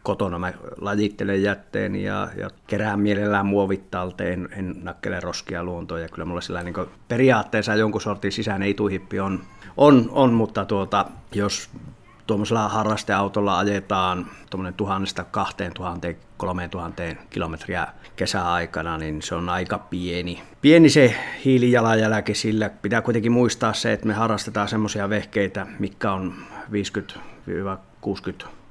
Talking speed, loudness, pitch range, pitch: 130 wpm, -23 LUFS, 90-110 Hz, 100 Hz